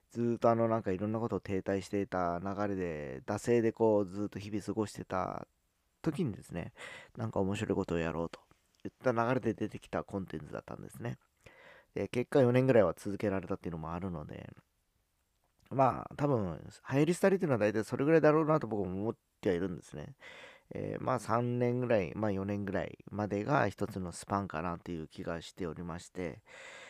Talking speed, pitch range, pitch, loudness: 395 characters per minute, 90-115 Hz, 100 Hz, -34 LUFS